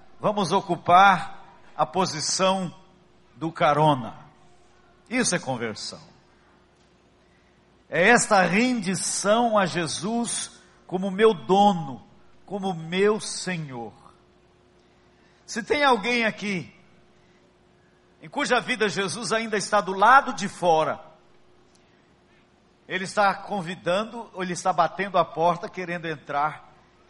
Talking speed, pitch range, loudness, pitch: 100 wpm, 170-210 Hz, -23 LUFS, 190 Hz